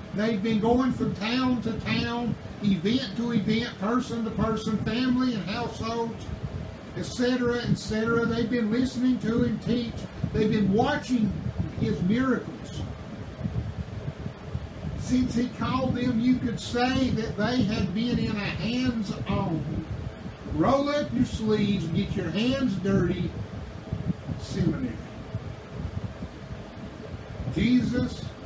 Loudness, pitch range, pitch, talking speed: -27 LUFS, 210-245 Hz, 230 Hz, 115 wpm